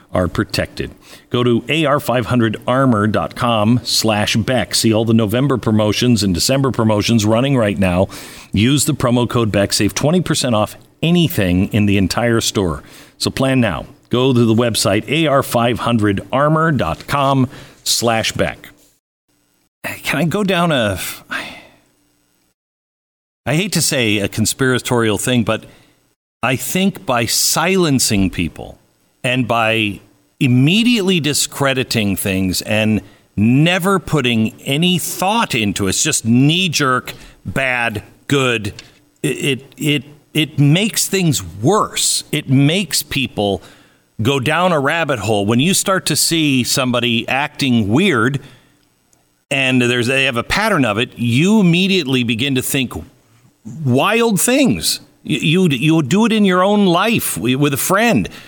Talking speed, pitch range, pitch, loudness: 130 wpm, 110-150 Hz, 125 Hz, -15 LUFS